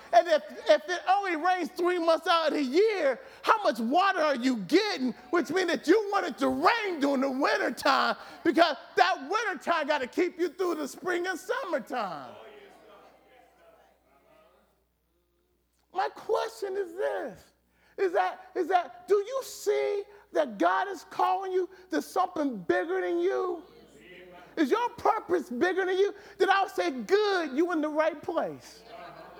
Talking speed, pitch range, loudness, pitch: 155 wpm, 310-390 Hz, -28 LUFS, 360 Hz